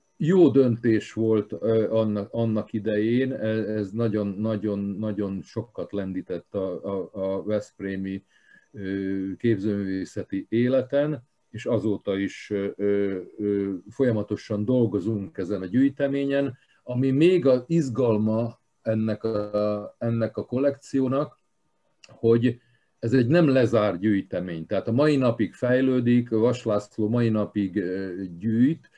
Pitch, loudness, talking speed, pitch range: 110 Hz, -25 LUFS, 110 wpm, 100-125 Hz